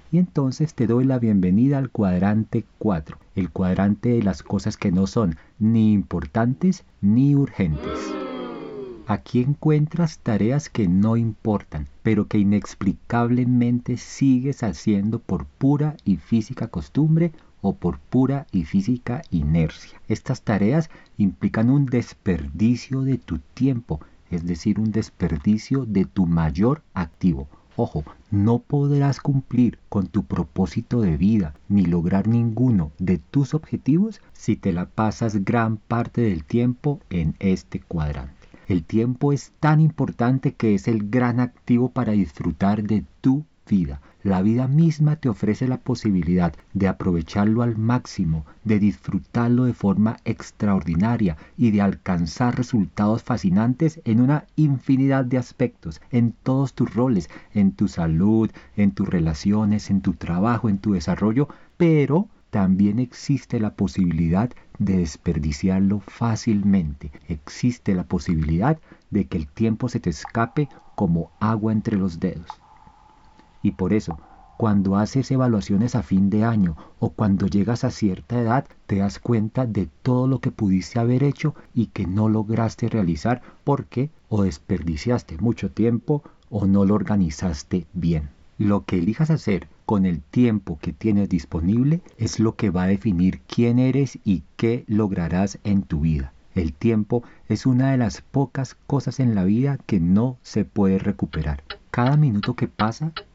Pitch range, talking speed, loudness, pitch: 95-125 Hz, 145 wpm, -22 LUFS, 110 Hz